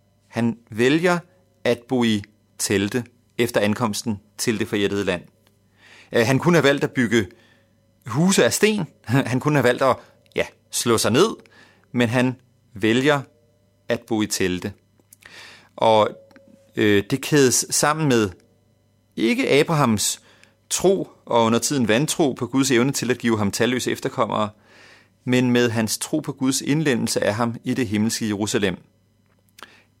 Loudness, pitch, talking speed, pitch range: -21 LUFS, 115 Hz, 145 wpm, 110-130 Hz